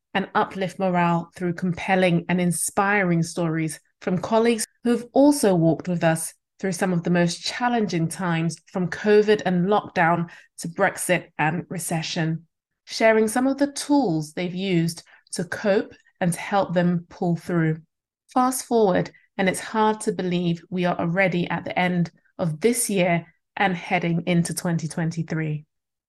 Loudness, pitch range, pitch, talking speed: -23 LUFS, 170-200 Hz, 180 Hz, 150 wpm